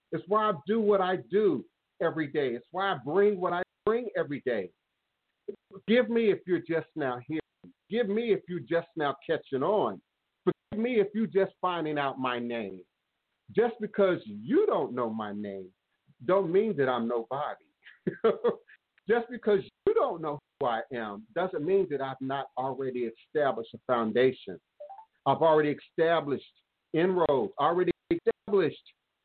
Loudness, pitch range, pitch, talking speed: -29 LUFS, 135-215 Hz, 180 Hz, 160 wpm